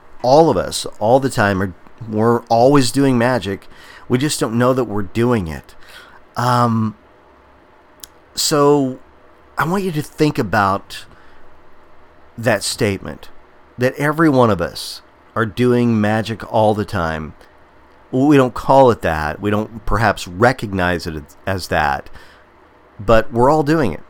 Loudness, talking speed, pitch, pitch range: -17 LUFS, 145 wpm, 115 Hz, 95-130 Hz